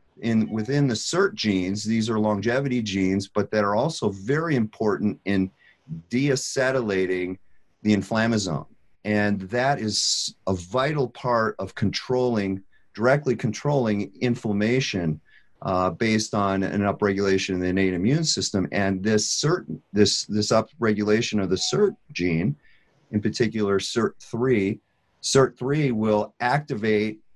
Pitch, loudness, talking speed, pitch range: 105 Hz, -24 LUFS, 125 wpm, 100-125 Hz